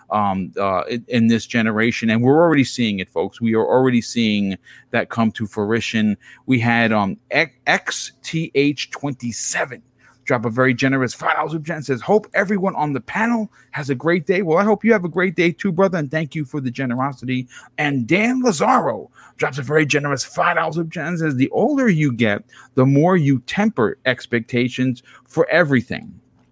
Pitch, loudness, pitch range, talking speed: 135 Hz, -19 LUFS, 120-170 Hz, 185 wpm